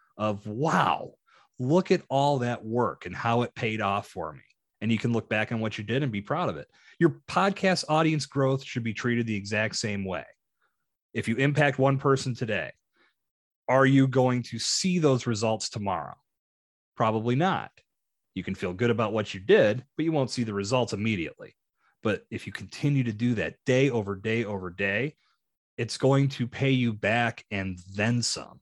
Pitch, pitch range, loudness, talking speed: 120 Hz, 110-135 Hz, -27 LUFS, 190 wpm